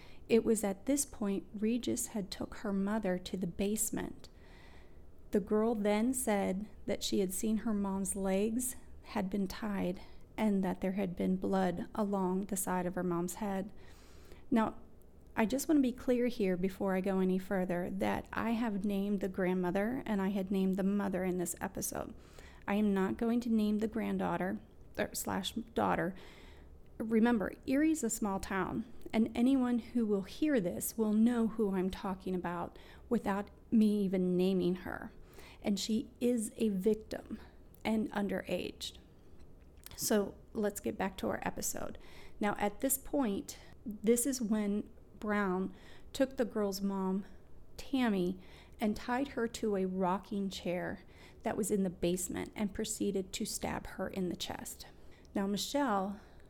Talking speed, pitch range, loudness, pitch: 160 wpm, 190-225 Hz, -35 LUFS, 205 Hz